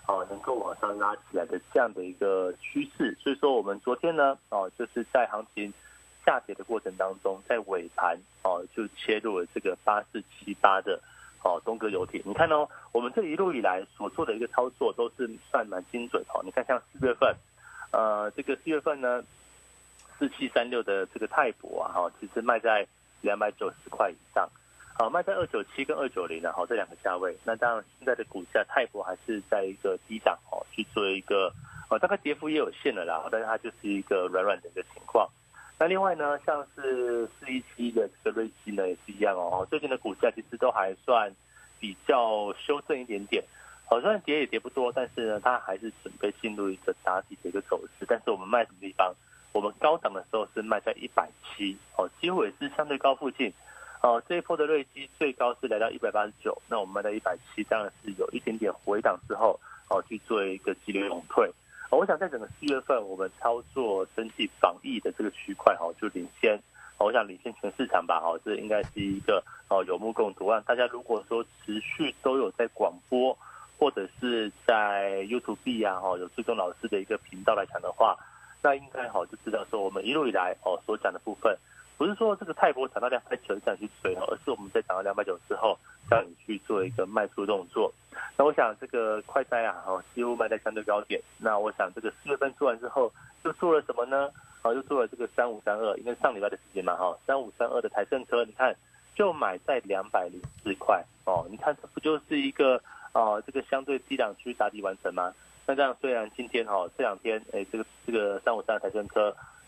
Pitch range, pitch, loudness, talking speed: 105-160 Hz, 125 Hz, -29 LUFS, 320 characters per minute